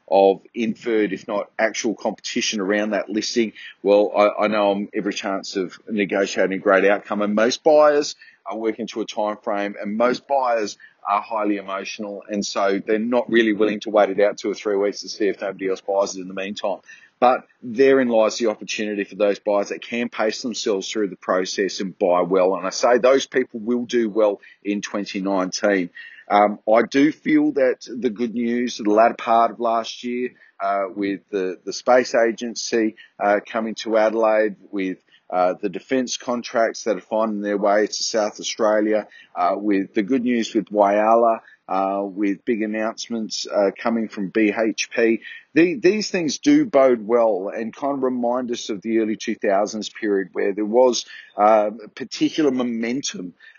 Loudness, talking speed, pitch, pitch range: -21 LUFS, 185 wpm, 110 Hz, 100-120 Hz